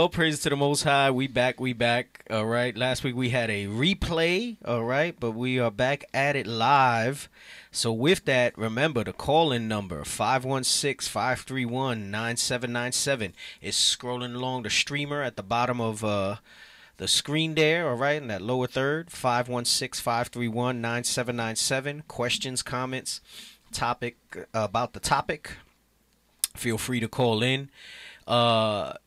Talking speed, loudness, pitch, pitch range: 150 wpm, -26 LUFS, 125 Hz, 115-140 Hz